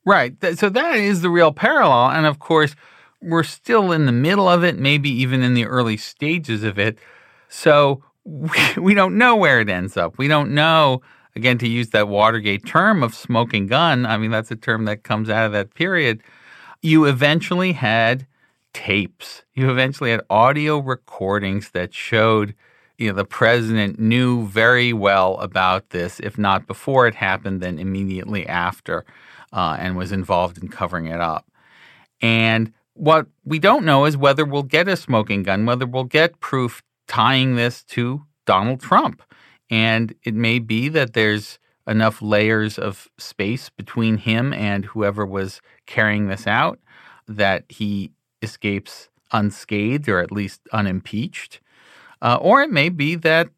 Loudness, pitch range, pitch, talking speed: -18 LUFS, 105-150 Hz, 115 Hz, 160 wpm